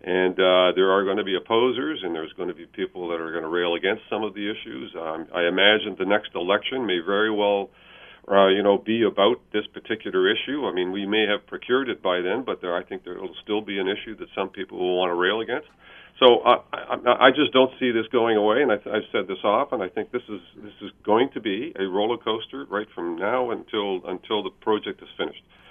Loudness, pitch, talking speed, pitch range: -23 LUFS, 100 Hz, 245 wpm, 90-110 Hz